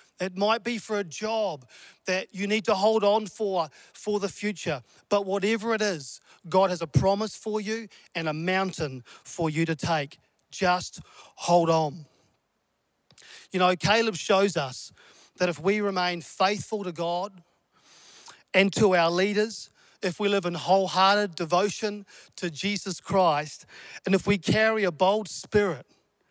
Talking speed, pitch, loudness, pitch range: 155 wpm, 190 Hz, -26 LUFS, 170-205 Hz